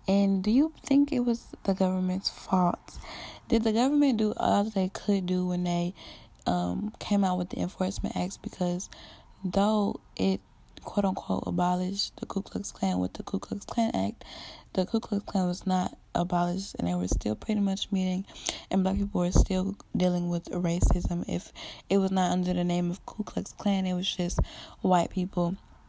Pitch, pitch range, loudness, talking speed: 185 Hz, 175-205 Hz, -29 LUFS, 185 wpm